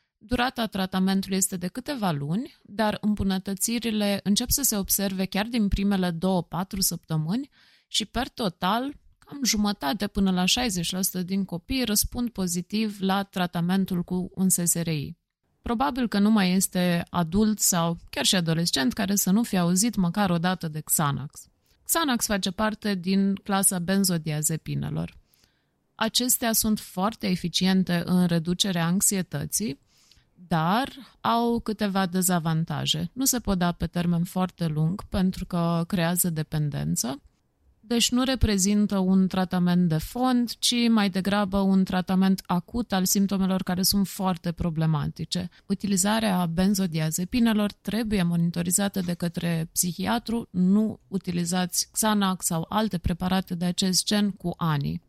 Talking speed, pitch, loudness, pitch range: 130 wpm, 190 Hz, -25 LUFS, 175-210 Hz